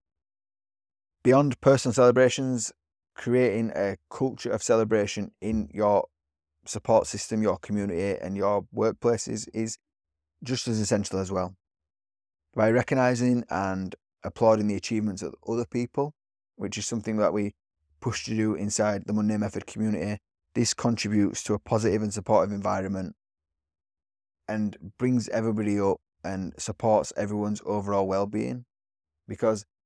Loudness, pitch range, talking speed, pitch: -27 LUFS, 95-115 Hz, 125 wpm, 105 Hz